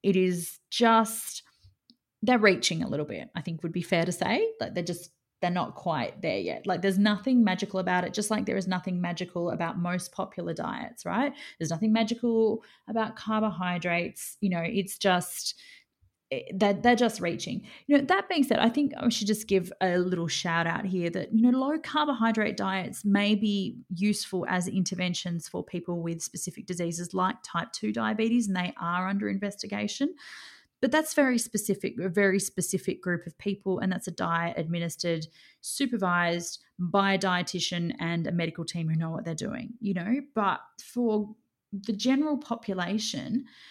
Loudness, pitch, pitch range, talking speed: -28 LUFS, 195 Hz, 175-225 Hz, 175 wpm